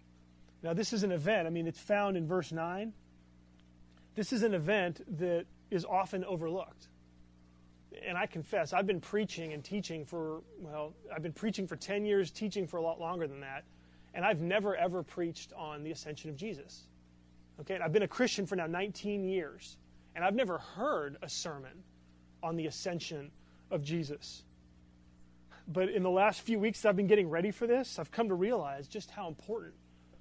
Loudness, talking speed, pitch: -35 LUFS, 185 wpm, 165 Hz